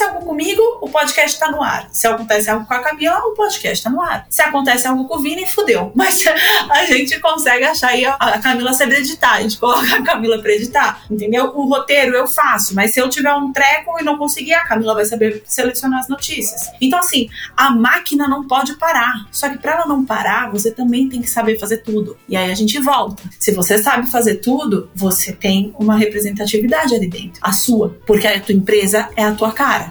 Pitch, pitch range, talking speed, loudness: 250 Hz, 215-290 Hz, 220 wpm, -14 LUFS